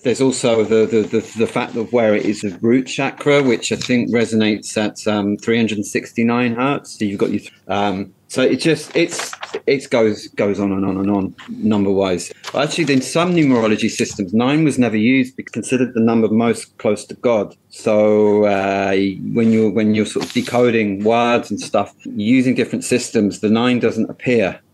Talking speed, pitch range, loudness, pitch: 185 wpm, 105-125 Hz, -17 LUFS, 115 Hz